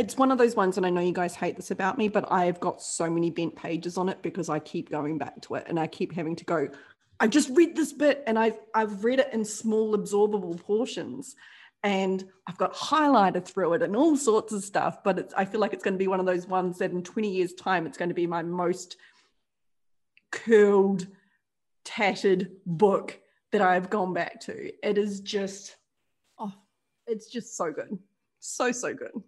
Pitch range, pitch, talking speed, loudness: 180-220 Hz, 195 Hz, 215 wpm, -27 LUFS